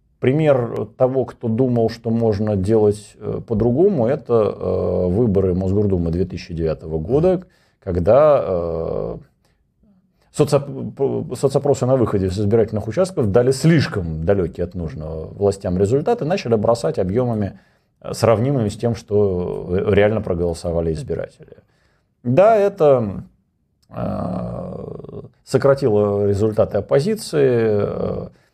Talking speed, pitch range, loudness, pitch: 90 wpm, 95-135 Hz, -19 LUFS, 110 Hz